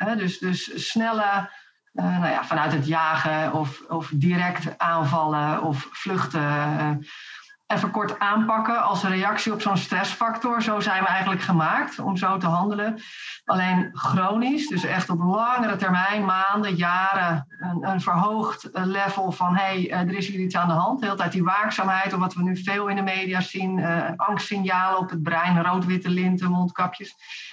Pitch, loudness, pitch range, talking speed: 185 Hz, -23 LUFS, 175-200 Hz, 175 wpm